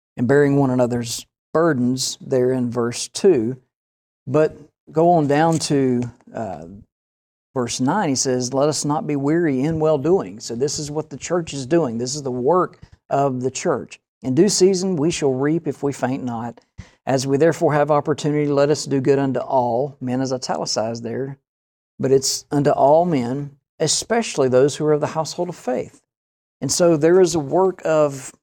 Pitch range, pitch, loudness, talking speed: 125-155 Hz, 140 Hz, -19 LUFS, 185 wpm